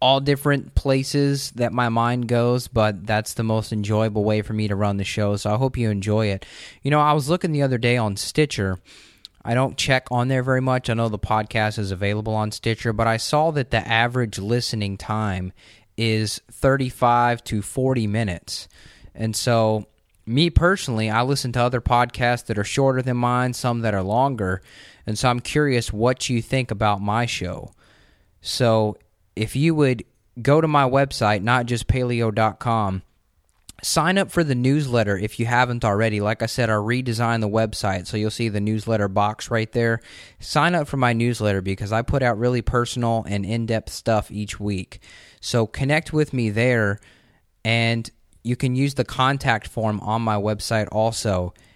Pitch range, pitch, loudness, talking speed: 105-125 Hz, 115 Hz, -22 LUFS, 185 wpm